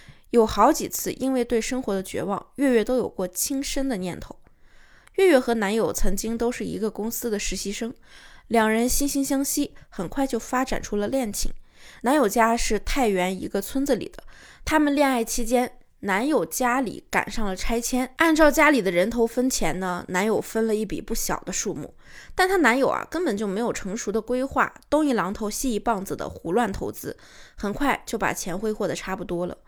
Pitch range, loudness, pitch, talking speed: 210-265 Hz, -24 LUFS, 230 Hz, 285 characters per minute